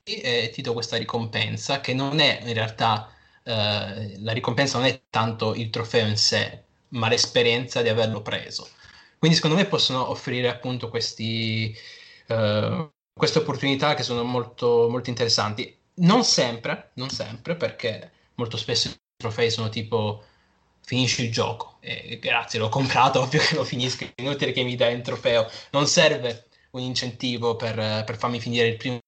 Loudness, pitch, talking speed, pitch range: -23 LUFS, 120 Hz, 160 wpm, 115-130 Hz